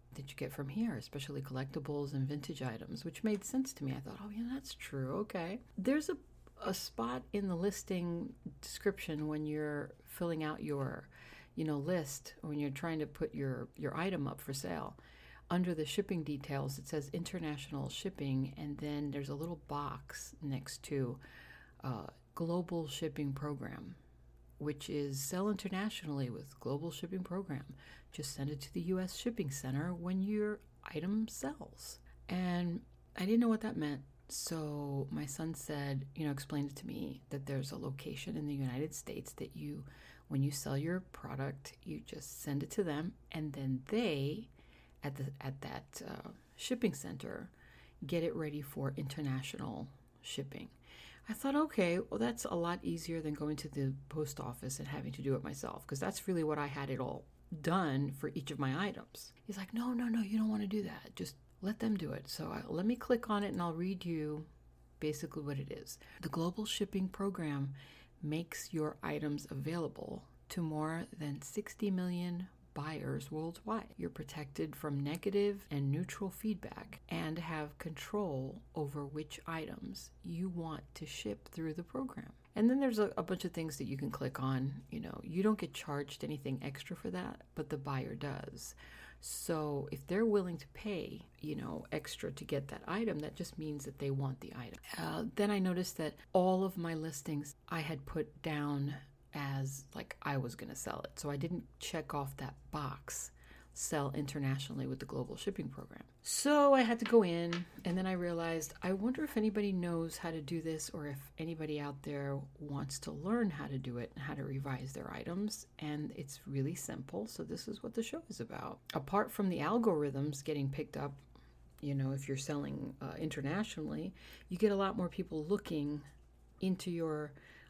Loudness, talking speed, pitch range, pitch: -39 LUFS, 185 wpm, 140-185 Hz, 150 Hz